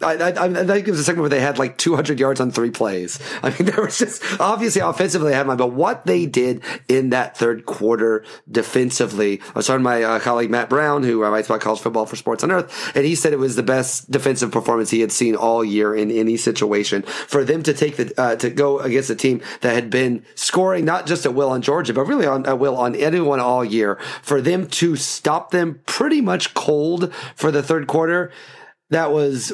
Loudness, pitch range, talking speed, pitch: -19 LUFS, 115-160 Hz, 235 wpm, 135 Hz